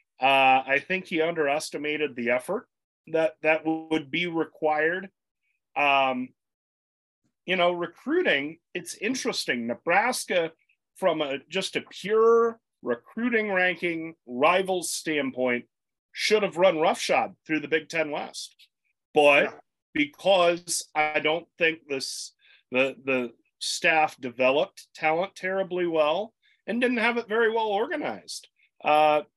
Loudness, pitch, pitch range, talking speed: -25 LUFS, 160 Hz, 145-185 Hz, 115 wpm